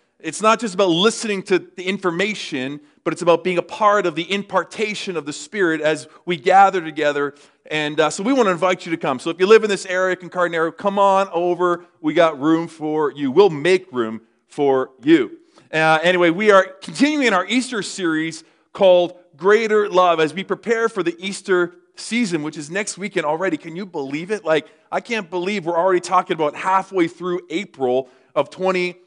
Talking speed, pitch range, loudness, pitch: 195 wpm, 160-195 Hz, -19 LUFS, 180 Hz